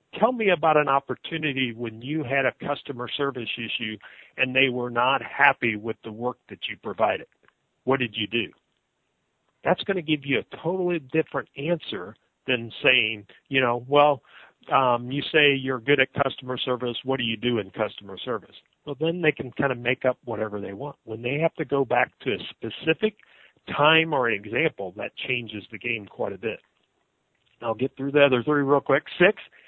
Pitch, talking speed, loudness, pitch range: 130 Hz, 190 wpm, -24 LUFS, 120-150 Hz